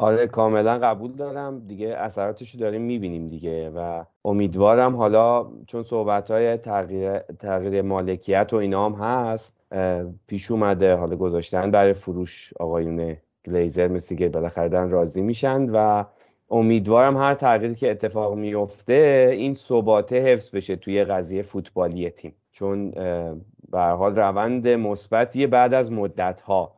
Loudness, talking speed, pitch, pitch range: -22 LUFS, 130 wpm, 100 Hz, 90-115 Hz